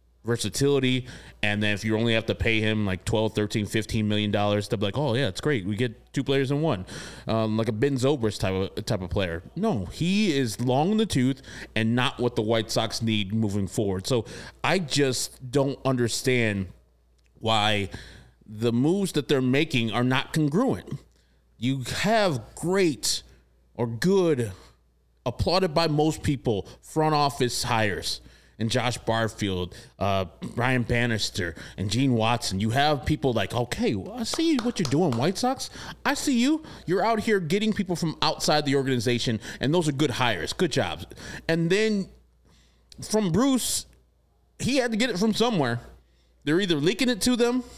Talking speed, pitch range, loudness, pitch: 175 wpm, 105-155 Hz, -25 LUFS, 125 Hz